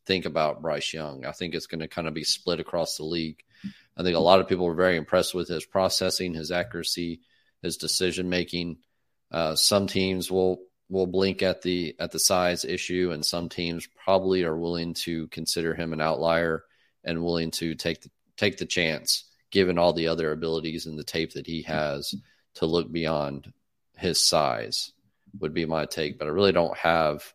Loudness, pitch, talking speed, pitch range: -26 LUFS, 85 Hz, 195 wpm, 80-90 Hz